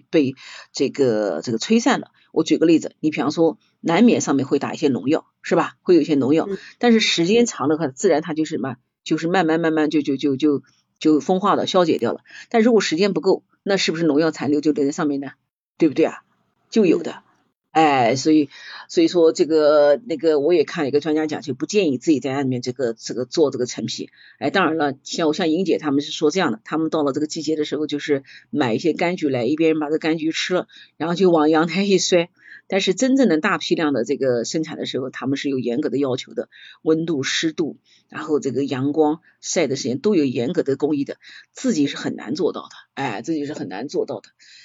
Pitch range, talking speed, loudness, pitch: 145-175 Hz, 335 characters per minute, -20 LUFS, 155 Hz